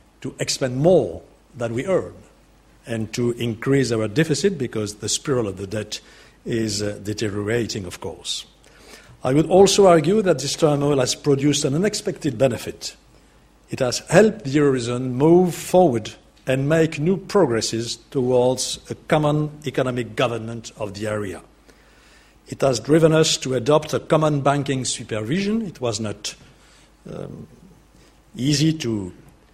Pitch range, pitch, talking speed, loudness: 115-160 Hz, 135 Hz, 140 wpm, -20 LUFS